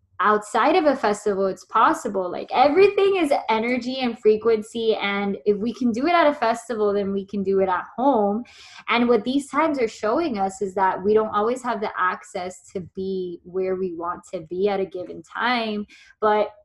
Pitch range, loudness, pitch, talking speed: 195-240 Hz, -22 LUFS, 210 Hz, 200 wpm